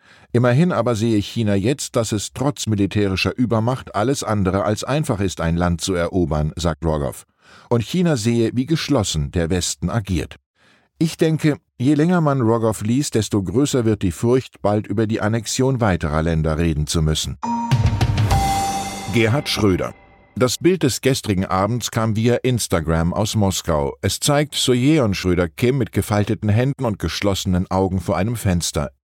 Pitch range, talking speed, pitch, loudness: 95-125 Hz, 160 wpm, 105 Hz, -19 LUFS